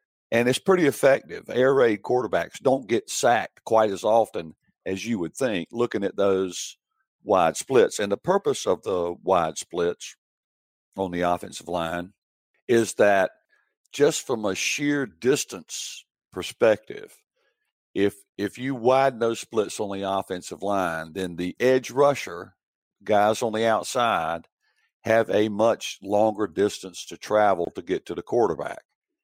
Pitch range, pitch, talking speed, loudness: 95-130 Hz, 110 Hz, 145 wpm, -24 LUFS